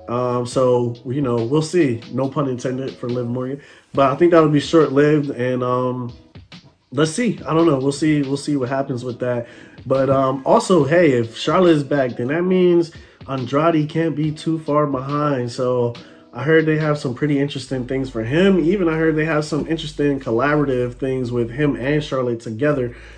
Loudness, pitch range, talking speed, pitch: -19 LUFS, 125-155 Hz, 195 wpm, 140 Hz